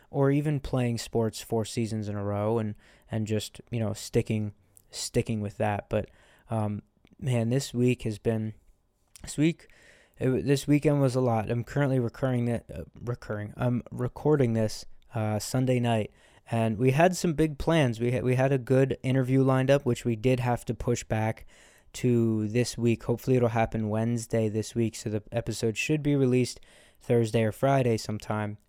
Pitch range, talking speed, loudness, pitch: 110-130 Hz, 180 wpm, -28 LUFS, 120 Hz